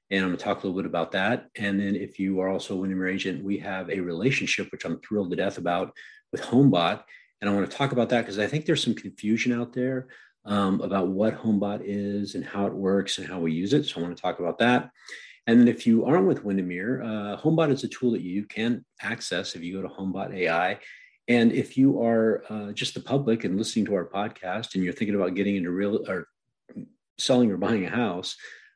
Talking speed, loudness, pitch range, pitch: 240 wpm, -26 LUFS, 95-120 Hz, 100 Hz